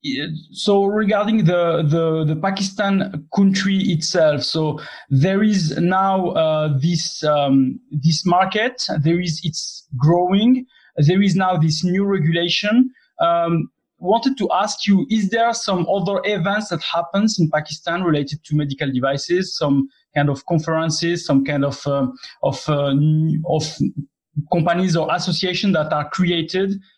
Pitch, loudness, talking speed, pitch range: 170 Hz, -19 LUFS, 140 wpm, 155-195 Hz